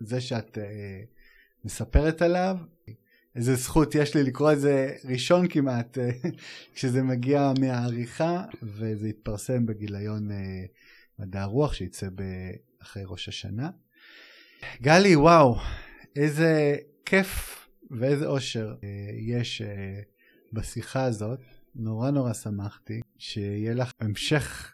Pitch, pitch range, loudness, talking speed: 125 Hz, 105-145 Hz, -26 LUFS, 110 wpm